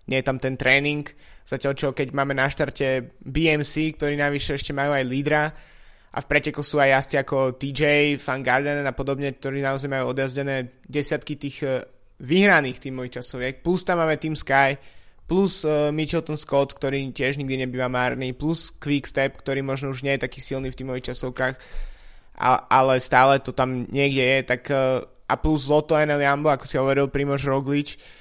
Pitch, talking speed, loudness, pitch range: 140 Hz, 175 wpm, -23 LUFS, 130-145 Hz